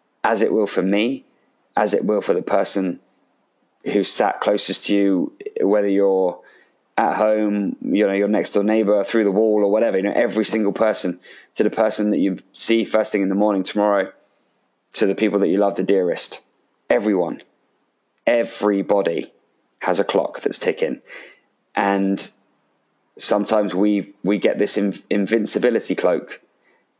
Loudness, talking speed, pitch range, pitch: -20 LUFS, 160 wpm, 100-110 Hz, 105 Hz